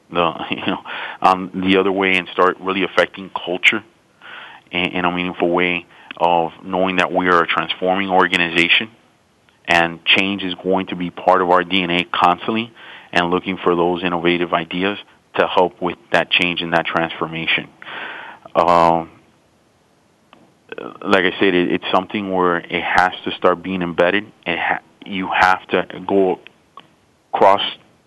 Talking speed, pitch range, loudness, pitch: 150 wpm, 85-95 Hz, -17 LUFS, 90 Hz